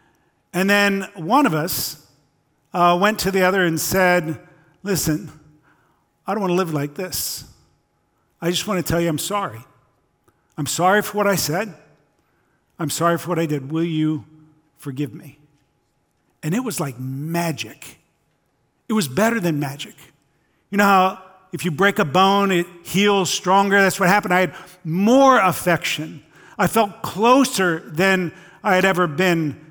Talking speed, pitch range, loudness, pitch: 160 wpm, 155-195 Hz, -19 LUFS, 175 Hz